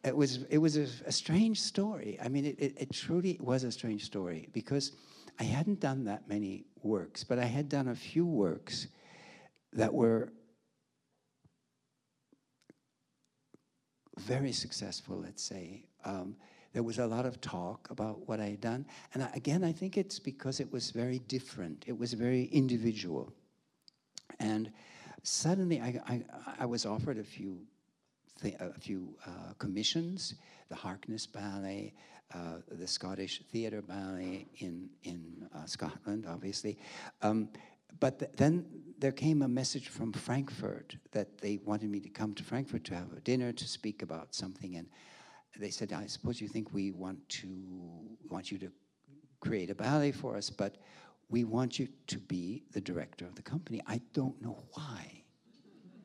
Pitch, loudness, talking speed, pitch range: 120 Hz, -37 LUFS, 160 wpm, 100-140 Hz